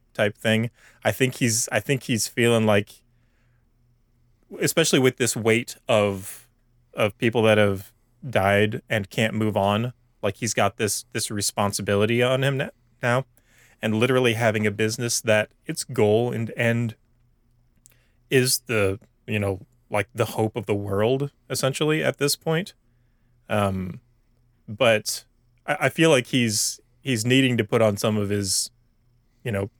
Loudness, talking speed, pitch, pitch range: -23 LUFS, 150 wpm, 120 Hz, 110-120 Hz